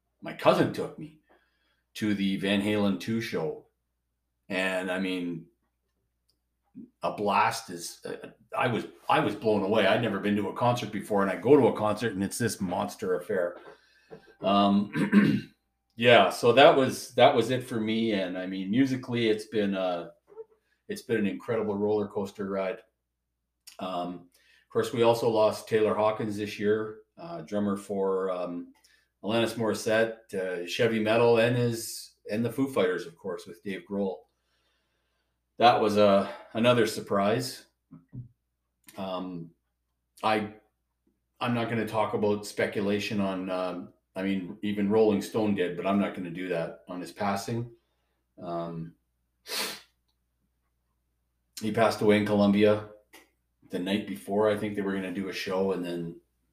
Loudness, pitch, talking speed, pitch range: -27 LUFS, 100 Hz, 155 wpm, 85-110 Hz